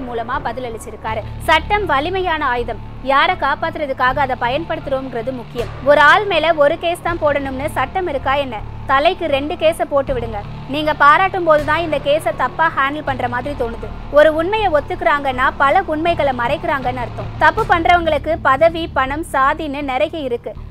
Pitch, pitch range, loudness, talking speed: 300 Hz, 275-330 Hz, -16 LUFS, 150 wpm